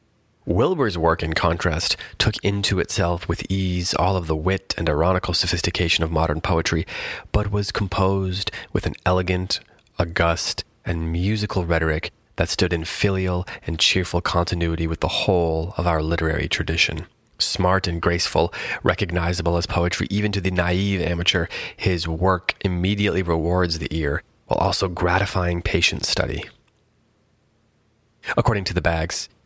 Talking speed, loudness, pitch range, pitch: 140 wpm, -22 LUFS, 85-95 Hz, 90 Hz